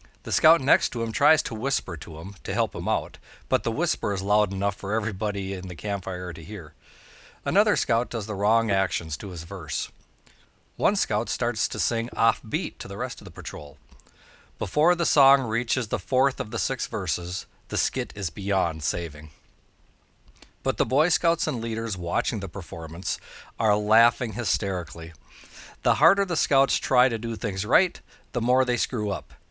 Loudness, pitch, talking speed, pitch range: -25 LUFS, 105 Hz, 185 wpm, 90-120 Hz